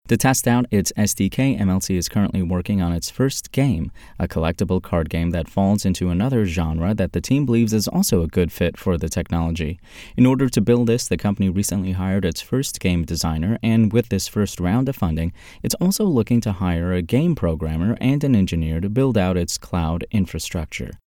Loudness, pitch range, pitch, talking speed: -20 LUFS, 85-115 Hz, 95 Hz, 200 wpm